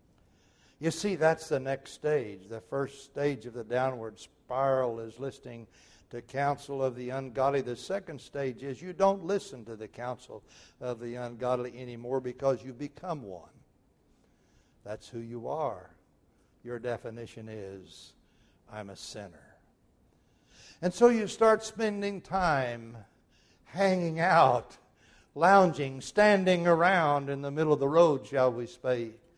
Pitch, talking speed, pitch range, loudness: 130 Hz, 140 wpm, 120-160 Hz, -29 LUFS